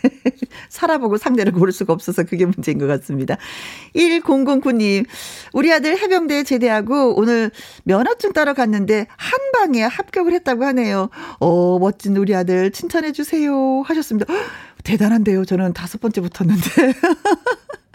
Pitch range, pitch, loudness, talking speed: 200-315 Hz, 250 Hz, -17 LUFS, 310 characters per minute